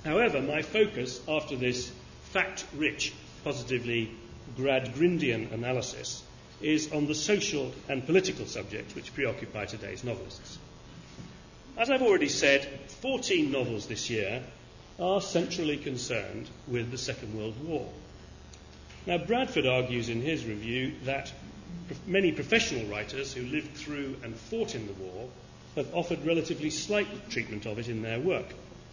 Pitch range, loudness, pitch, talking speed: 115-170 Hz, -31 LUFS, 135 Hz, 135 wpm